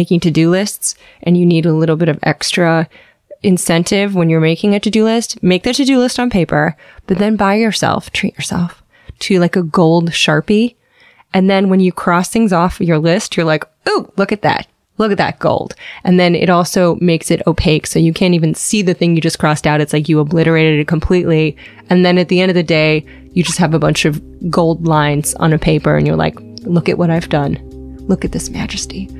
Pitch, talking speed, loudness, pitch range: 170 Hz, 230 wpm, -13 LUFS, 160-190 Hz